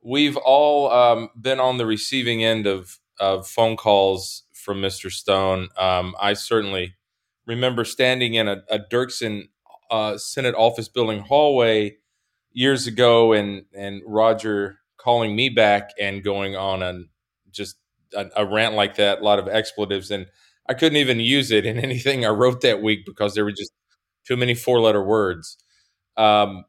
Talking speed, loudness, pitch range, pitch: 165 wpm, -20 LUFS, 100-120 Hz, 110 Hz